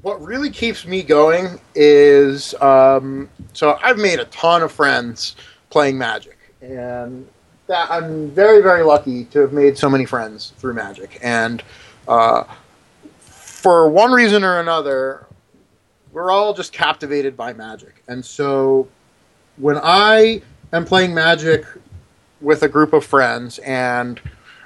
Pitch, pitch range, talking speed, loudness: 145 Hz, 130-175 Hz, 135 wpm, -15 LUFS